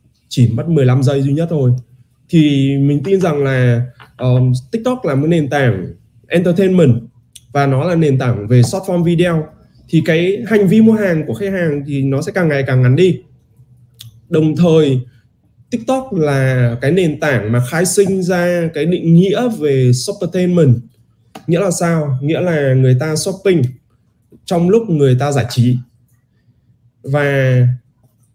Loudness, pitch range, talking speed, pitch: -14 LUFS, 125-170 Hz, 165 wpm, 140 Hz